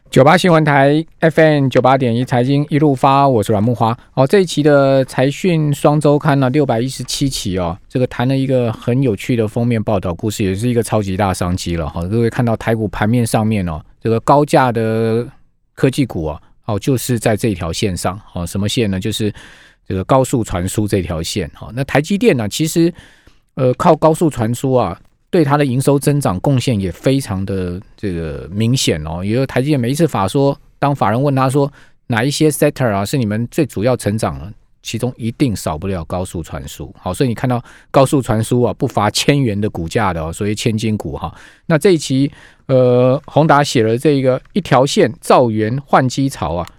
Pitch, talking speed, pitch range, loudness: 125 Hz, 310 characters per minute, 105-140 Hz, -15 LUFS